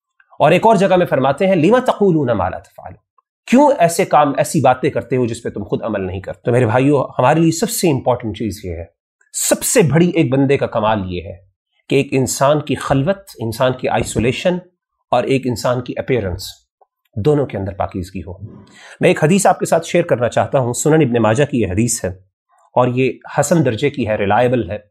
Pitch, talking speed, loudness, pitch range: 130 Hz, 215 wpm, -16 LUFS, 105-155 Hz